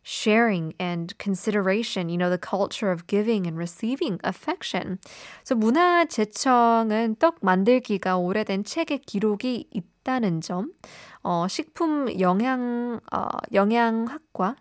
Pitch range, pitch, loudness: 185-250 Hz, 215 Hz, -24 LUFS